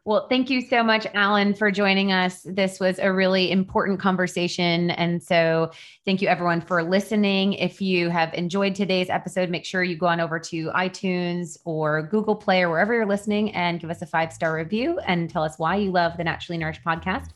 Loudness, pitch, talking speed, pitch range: -23 LUFS, 185 Hz, 205 wpm, 170-195 Hz